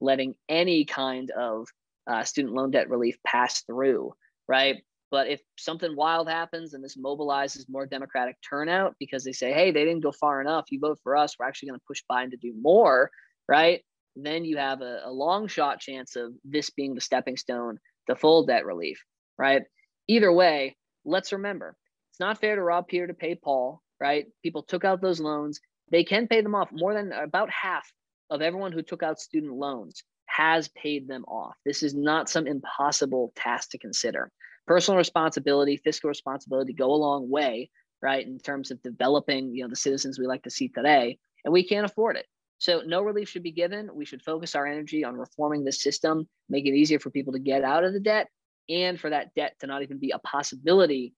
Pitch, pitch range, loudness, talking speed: 145 Hz, 135-170 Hz, -26 LUFS, 205 wpm